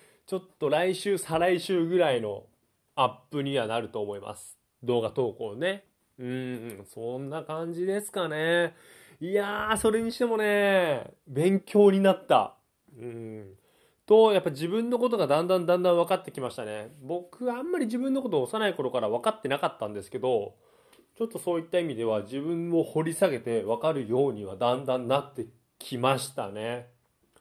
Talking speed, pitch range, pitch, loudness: 340 characters per minute, 125-195 Hz, 165 Hz, -27 LUFS